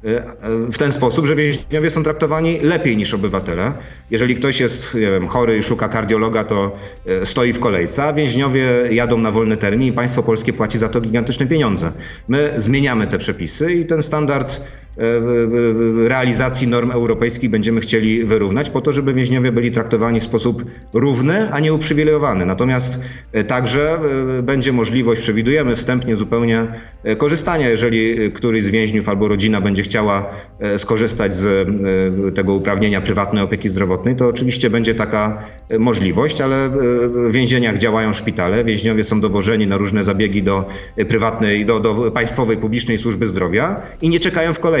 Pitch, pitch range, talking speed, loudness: 115 Hz, 110-130 Hz, 155 wpm, -16 LUFS